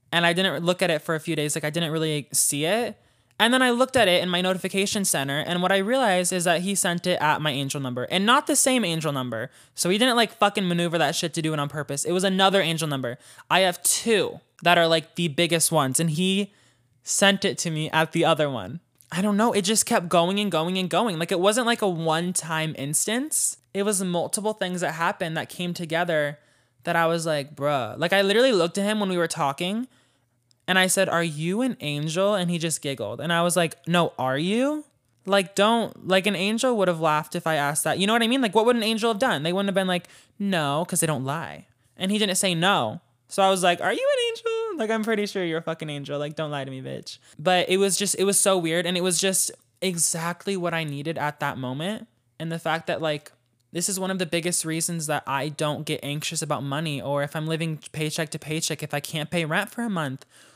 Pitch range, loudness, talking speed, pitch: 155-195 Hz, -23 LUFS, 255 wpm, 170 Hz